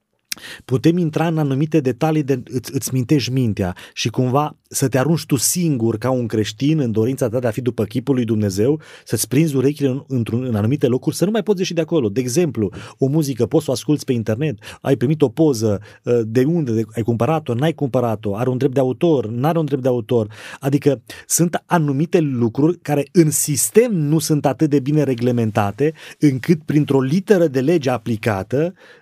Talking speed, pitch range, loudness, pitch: 195 wpm, 120-155 Hz, -18 LUFS, 135 Hz